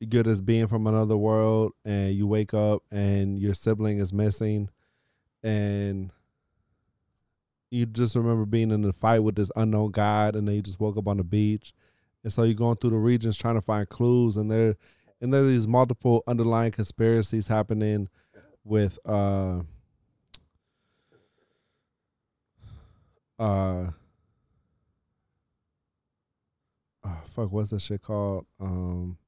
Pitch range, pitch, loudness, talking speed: 100-115 Hz, 105 Hz, -26 LUFS, 135 wpm